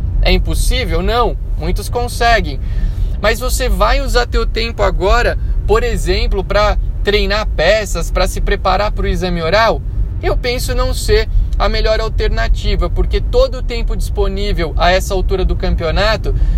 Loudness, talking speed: -16 LUFS, 150 wpm